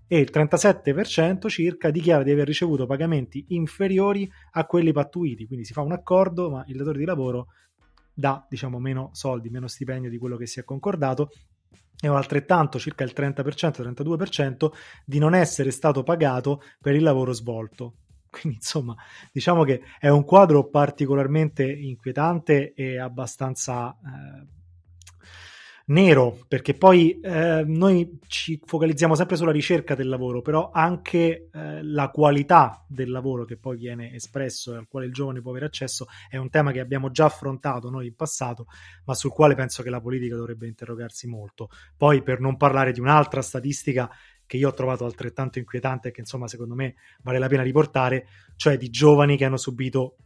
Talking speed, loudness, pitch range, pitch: 170 wpm, -23 LUFS, 125-155 Hz, 135 Hz